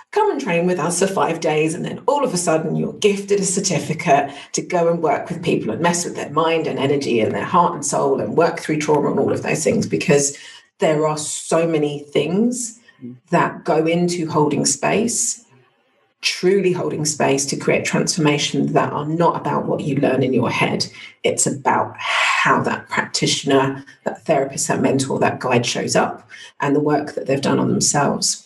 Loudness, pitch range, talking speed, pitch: -19 LUFS, 150-190 Hz, 195 wpm, 165 Hz